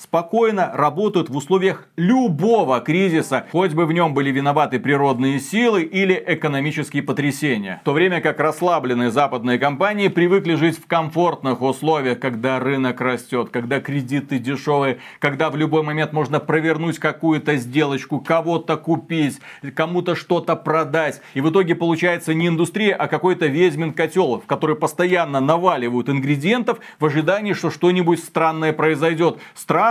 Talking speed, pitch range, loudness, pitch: 140 wpm, 140-170 Hz, -19 LUFS, 160 Hz